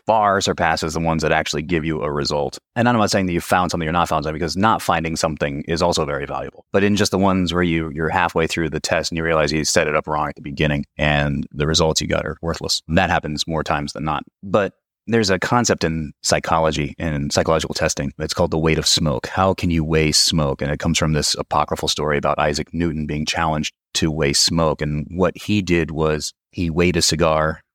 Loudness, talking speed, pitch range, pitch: -19 LUFS, 240 wpm, 75-85 Hz, 80 Hz